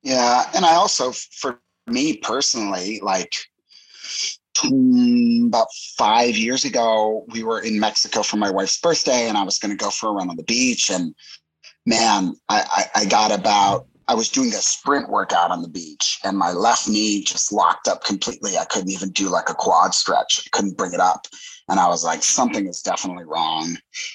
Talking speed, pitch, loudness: 190 wpm, 120 Hz, -19 LUFS